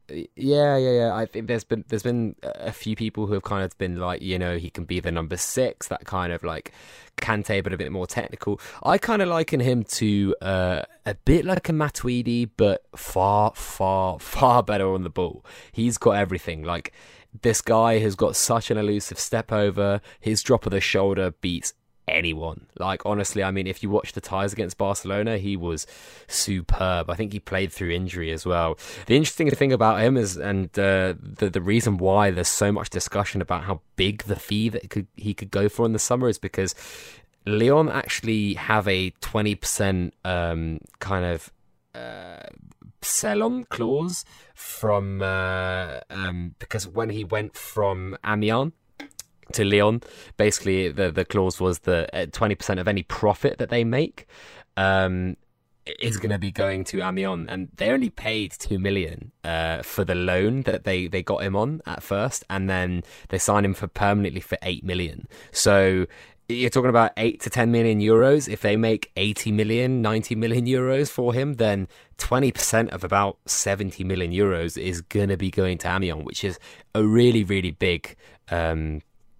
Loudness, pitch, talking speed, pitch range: -24 LUFS, 100 Hz, 185 wpm, 95-115 Hz